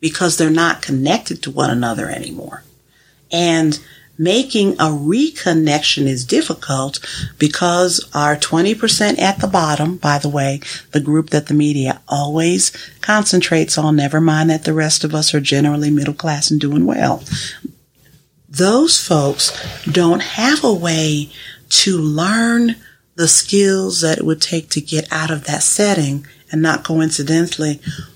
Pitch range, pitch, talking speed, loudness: 150-175 Hz, 155 Hz, 145 wpm, -15 LUFS